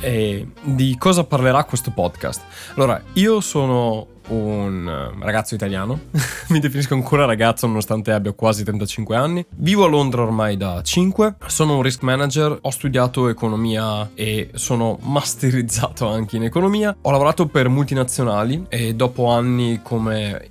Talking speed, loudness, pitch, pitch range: 140 wpm, -19 LUFS, 125 Hz, 110-140 Hz